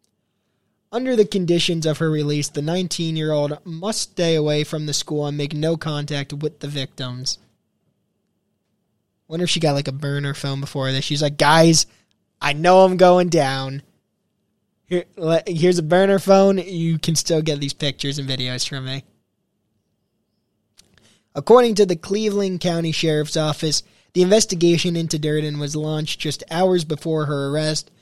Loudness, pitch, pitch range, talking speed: -19 LUFS, 155 Hz, 145-180 Hz, 155 wpm